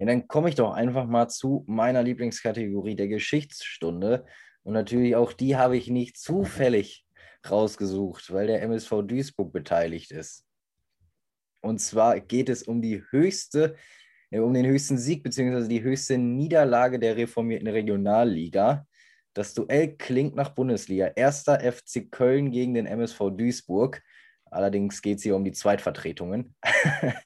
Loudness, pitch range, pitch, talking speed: -25 LUFS, 105-130 Hz, 120 Hz, 140 wpm